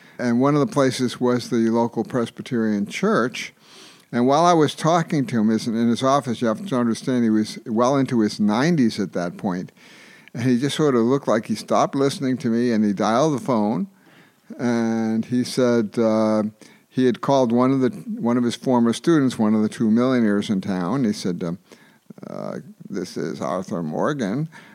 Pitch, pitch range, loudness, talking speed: 120 Hz, 115-135 Hz, -21 LUFS, 195 wpm